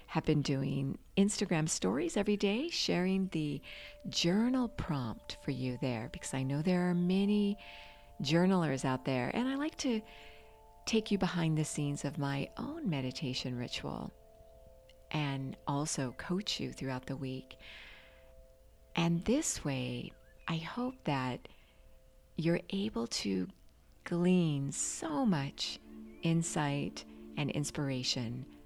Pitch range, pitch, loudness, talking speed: 125-185 Hz, 145 Hz, -35 LUFS, 125 wpm